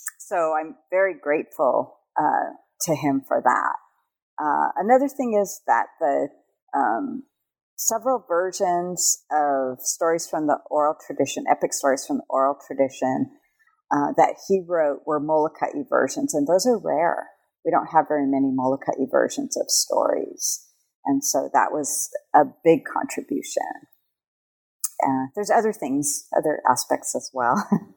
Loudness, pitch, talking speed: -23 LUFS, 180 Hz, 140 wpm